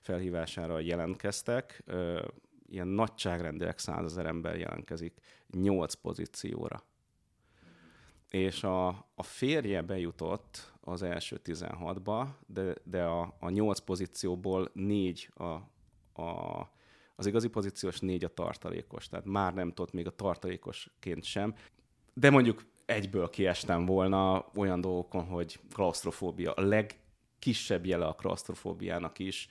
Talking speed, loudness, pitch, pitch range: 110 wpm, -34 LUFS, 95 Hz, 85-100 Hz